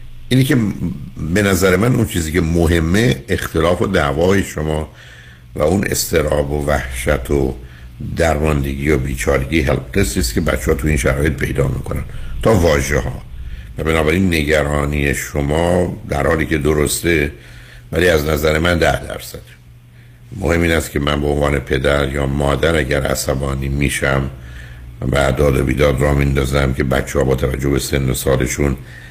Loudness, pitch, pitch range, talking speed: -16 LUFS, 70 Hz, 65-80 Hz, 155 wpm